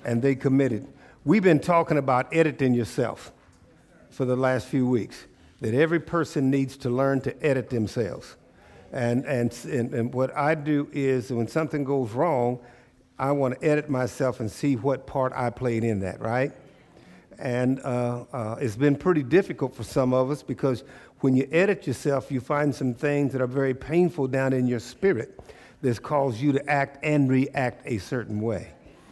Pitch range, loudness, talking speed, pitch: 125-145 Hz, -25 LUFS, 180 wpm, 130 Hz